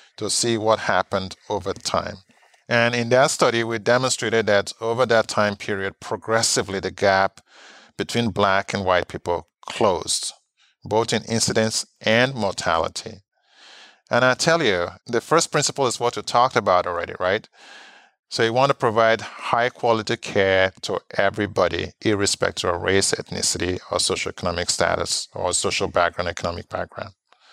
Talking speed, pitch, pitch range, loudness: 145 wpm, 110 Hz, 100-120 Hz, -21 LUFS